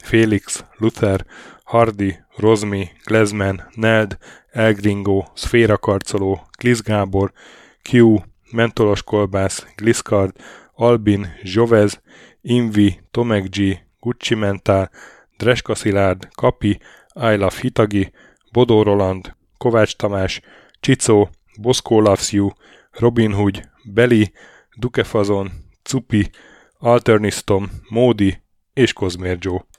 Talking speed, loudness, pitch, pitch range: 85 wpm, -18 LUFS, 105 Hz, 95-115 Hz